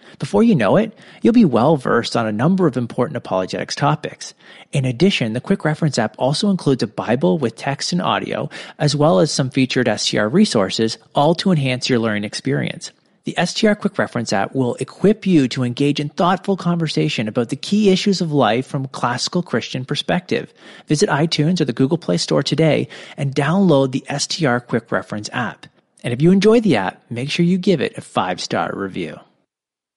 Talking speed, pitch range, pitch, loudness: 190 wpm, 120-180 Hz, 145 Hz, -18 LUFS